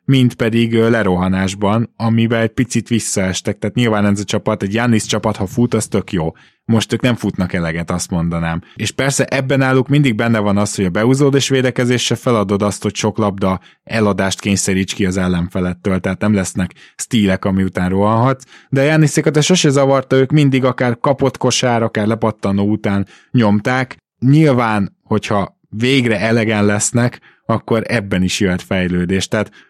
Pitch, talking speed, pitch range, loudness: 110 Hz, 170 wpm, 100-125 Hz, -15 LUFS